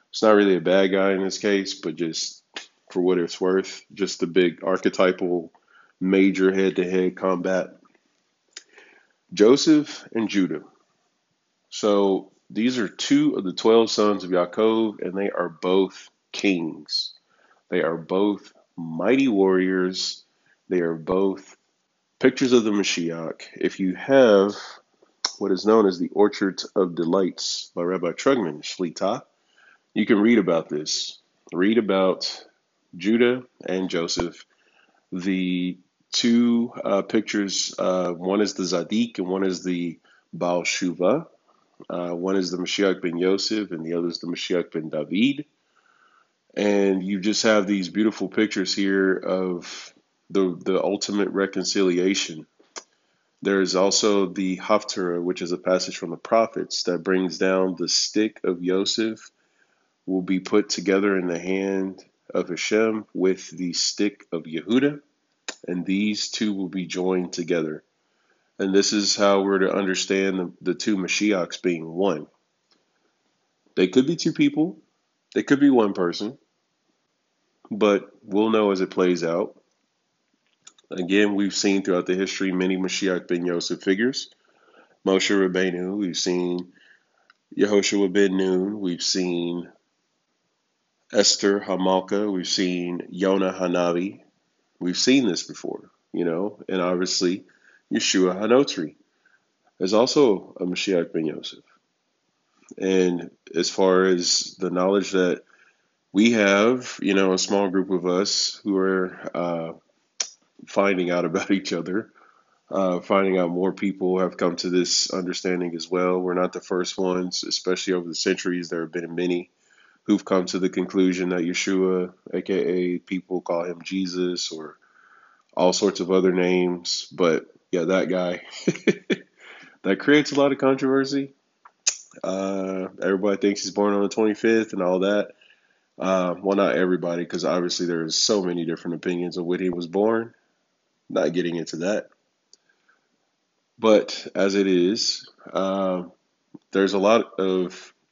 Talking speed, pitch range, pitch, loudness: 140 wpm, 90-100 Hz, 95 Hz, -23 LUFS